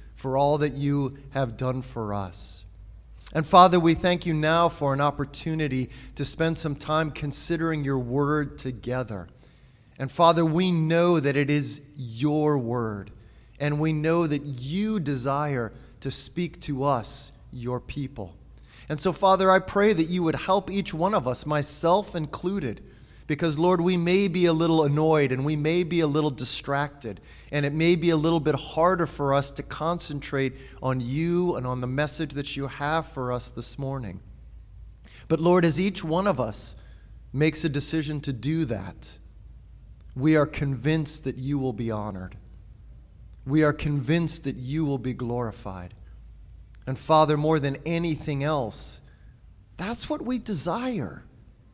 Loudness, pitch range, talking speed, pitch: -25 LUFS, 125-160 Hz, 160 wpm, 145 Hz